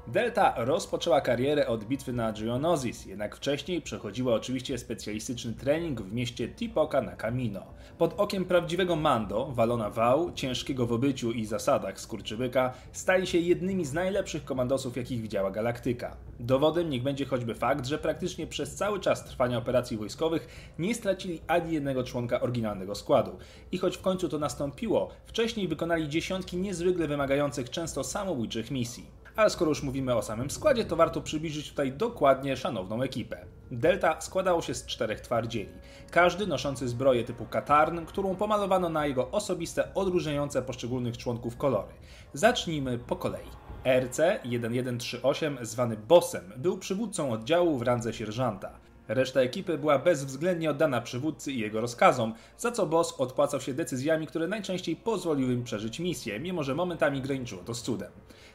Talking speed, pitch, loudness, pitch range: 150 wpm, 140 Hz, -29 LUFS, 120-170 Hz